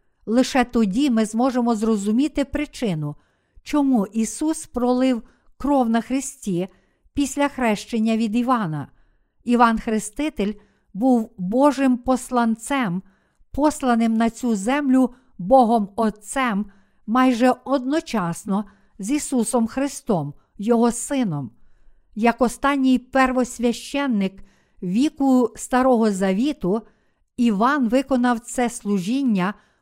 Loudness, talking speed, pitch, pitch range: -21 LUFS, 90 wpm, 240 Hz, 220-260 Hz